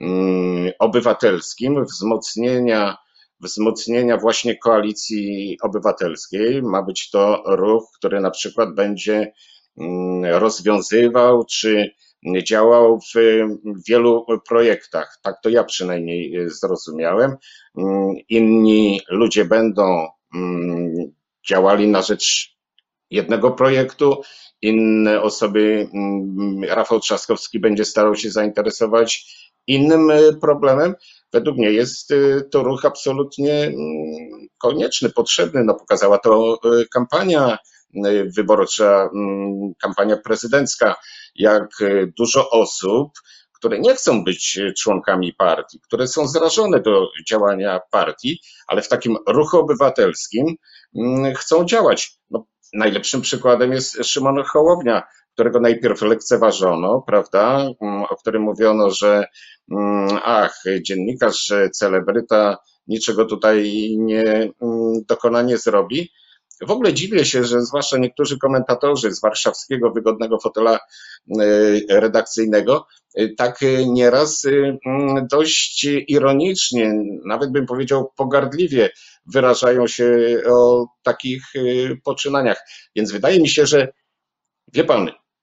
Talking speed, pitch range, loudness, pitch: 95 wpm, 105-130 Hz, -17 LUFS, 115 Hz